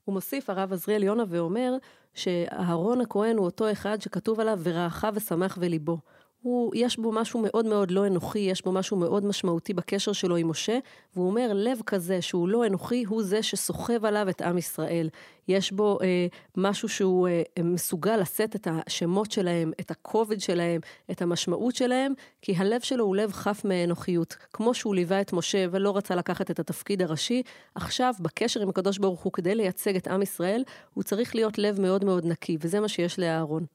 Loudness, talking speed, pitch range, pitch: -27 LUFS, 185 wpm, 175-215 Hz, 195 Hz